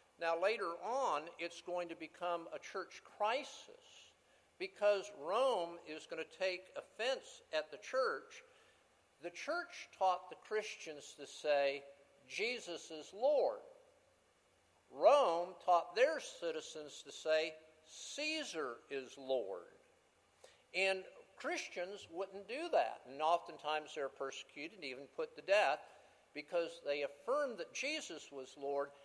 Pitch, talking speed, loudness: 180 Hz, 125 wpm, -39 LUFS